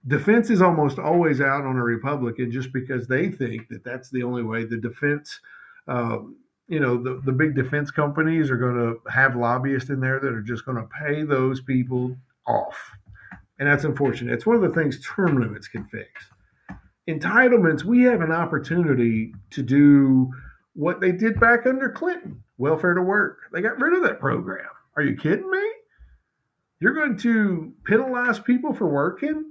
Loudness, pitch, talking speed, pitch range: -22 LUFS, 145 Hz, 180 wpm, 125-200 Hz